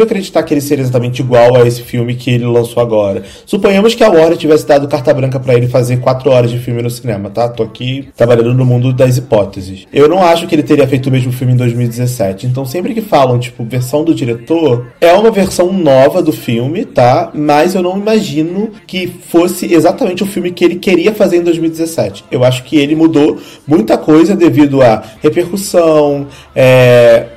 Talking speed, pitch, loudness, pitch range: 200 wpm, 145 Hz, -10 LUFS, 120-170 Hz